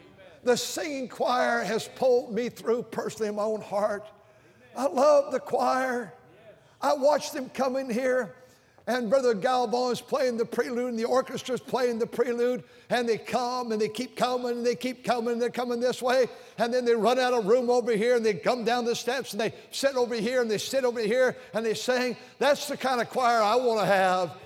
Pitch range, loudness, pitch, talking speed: 225-250 Hz, -27 LUFS, 240 Hz, 215 wpm